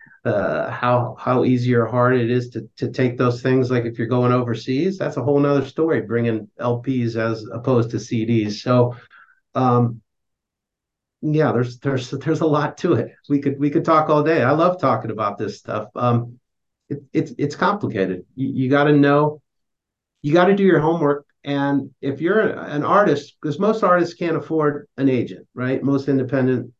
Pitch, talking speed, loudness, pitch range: 130 Hz, 185 wpm, -20 LUFS, 120-150 Hz